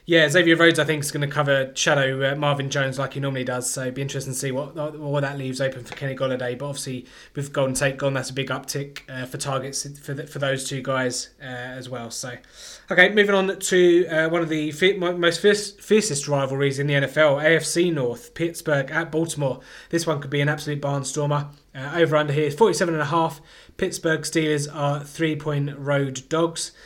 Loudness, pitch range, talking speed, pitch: -22 LUFS, 135-160 Hz, 215 wpm, 145 Hz